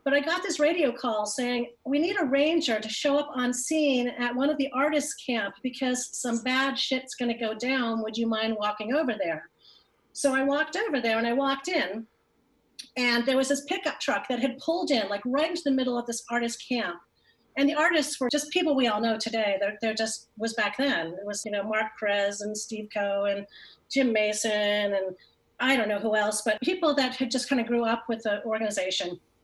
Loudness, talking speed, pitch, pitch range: -27 LUFS, 225 wpm, 245 Hz, 220-280 Hz